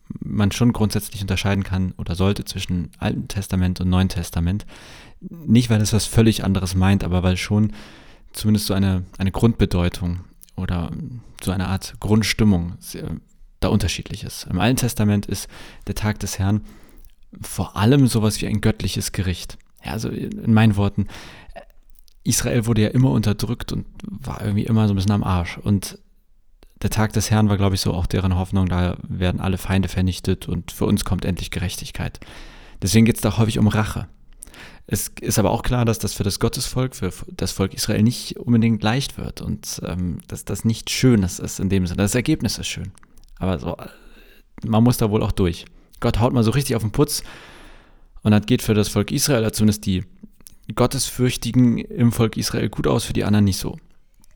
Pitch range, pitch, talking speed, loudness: 95-115 Hz, 105 Hz, 185 wpm, -21 LUFS